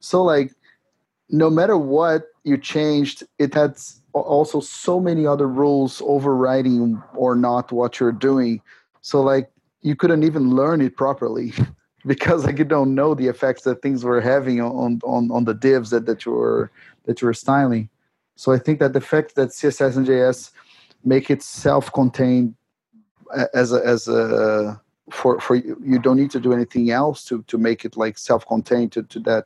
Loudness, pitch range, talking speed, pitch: -19 LUFS, 120-145 Hz, 180 wpm, 130 Hz